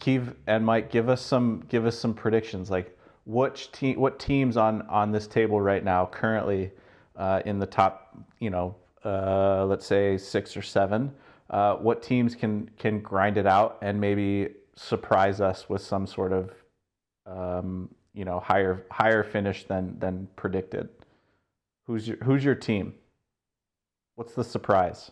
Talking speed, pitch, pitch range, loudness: 160 wpm, 100 Hz, 95-115 Hz, -27 LUFS